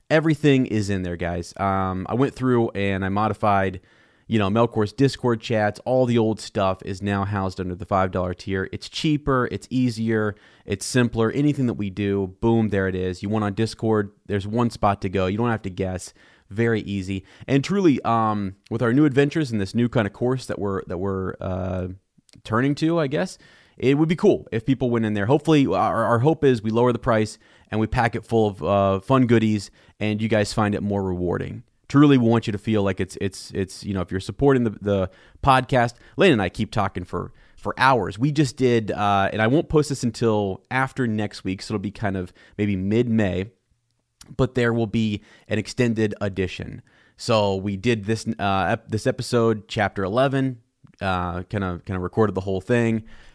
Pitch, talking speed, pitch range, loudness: 110 Hz, 210 wpm, 100-120 Hz, -22 LUFS